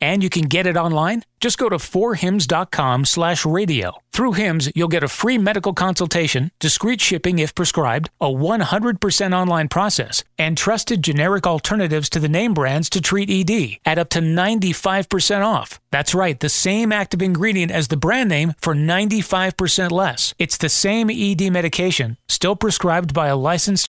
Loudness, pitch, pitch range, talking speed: -18 LUFS, 180 Hz, 160-200 Hz, 165 wpm